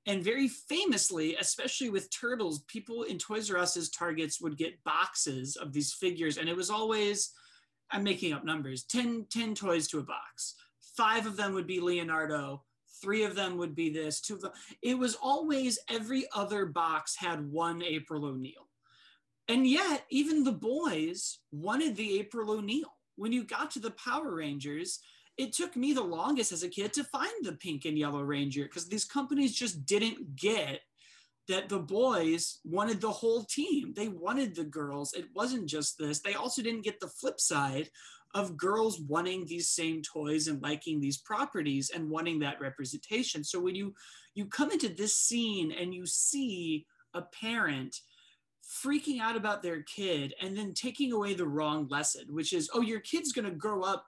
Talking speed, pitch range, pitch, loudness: 180 wpm, 160-235 Hz, 195 Hz, -33 LUFS